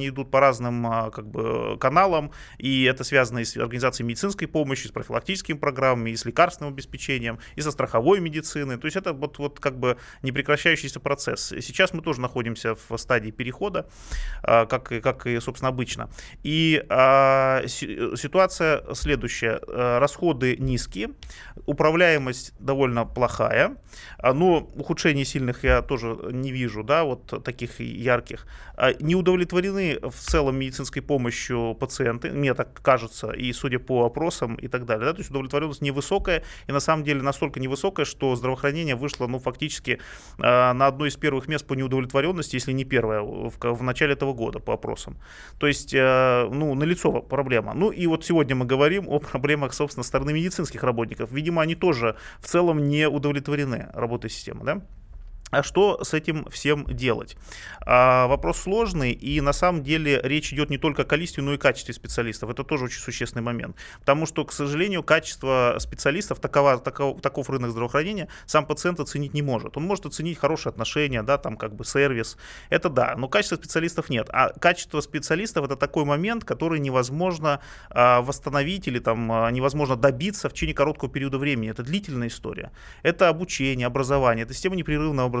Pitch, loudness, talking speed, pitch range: 140 Hz, -24 LUFS, 170 wpm, 125-155 Hz